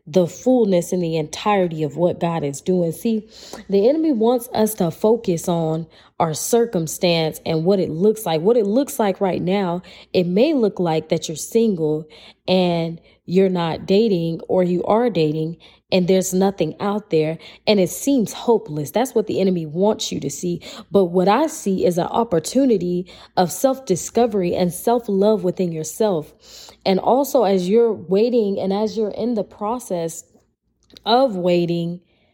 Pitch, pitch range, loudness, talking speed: 185 Hz, 170-215 Hz, -20 LUFS, 170 wpm